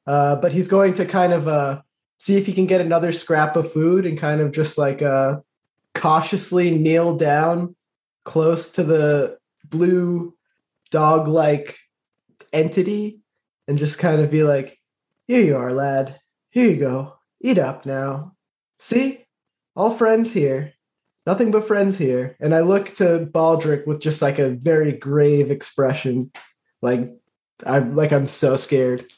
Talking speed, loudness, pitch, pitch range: 155 wpm, -19 LUFS, 155 Hz, 140-180 Hz